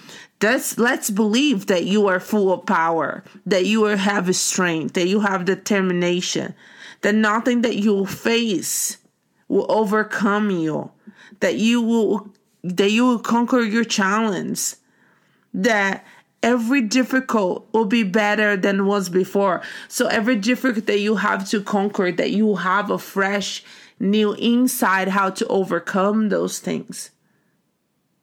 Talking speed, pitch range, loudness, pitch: 140 wpm, 195-225 Hz, -20 LUFS, 210 Hz